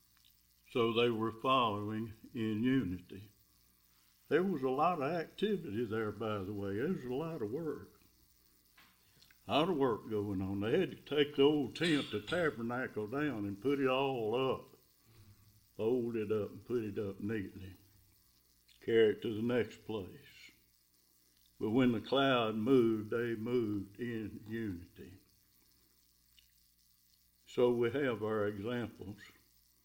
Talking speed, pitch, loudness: 145 wpm, 105 Hz, -35 LUFS